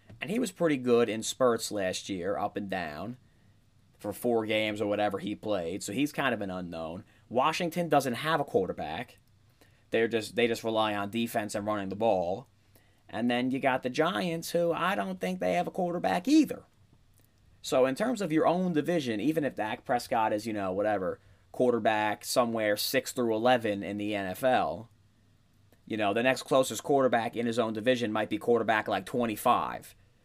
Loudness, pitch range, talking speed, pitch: -29 LUFS, 105-130 Hz, 190 wpm, 115 Hz